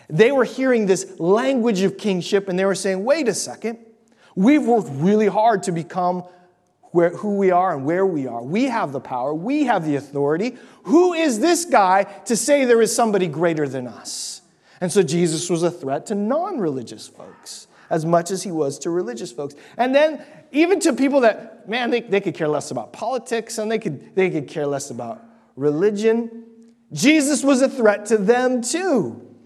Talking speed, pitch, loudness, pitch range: 195 wpm, 205 Hz, -20 LUFS, 175-240 Hz